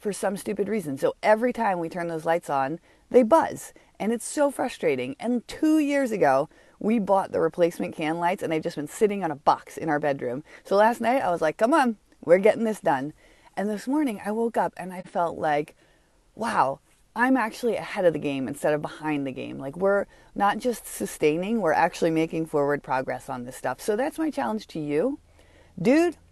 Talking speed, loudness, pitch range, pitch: 210 wpm, -25 LUFS, 155-230 Hz, 195 Hz